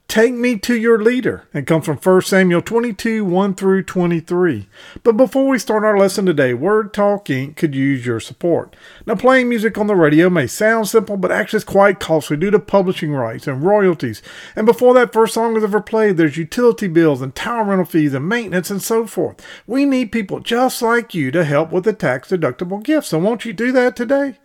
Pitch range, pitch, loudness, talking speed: 165-230 Hz, 200 Hz, -16 LUFS, 210 wpm